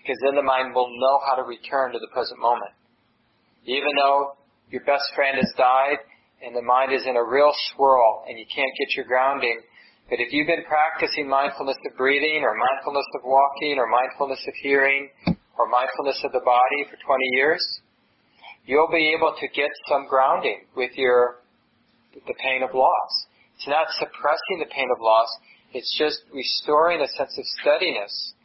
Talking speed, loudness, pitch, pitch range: 180 wpm, -22 LUFS, 135 Hz, 125-140 Hz